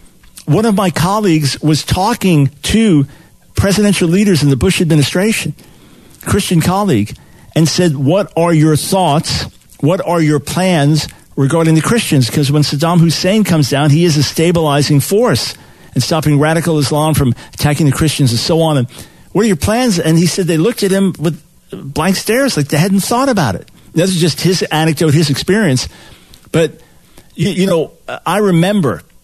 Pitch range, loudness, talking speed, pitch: 150-185 Hz, -13 LUFS, 170 wpm, 165 Hz